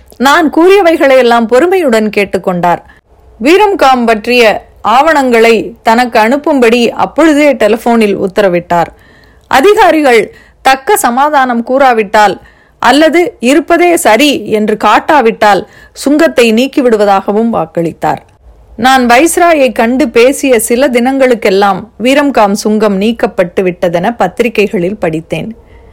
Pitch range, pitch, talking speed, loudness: 210-280 Hz, 235 Hz, 85 wpm, -8 LUFS